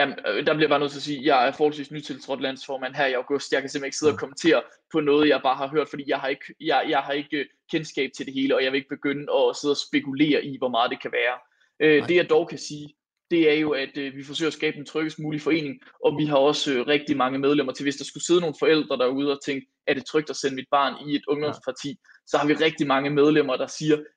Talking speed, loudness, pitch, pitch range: 270 wpm, -24 LUFS, 145 Hz, 140-155 Hz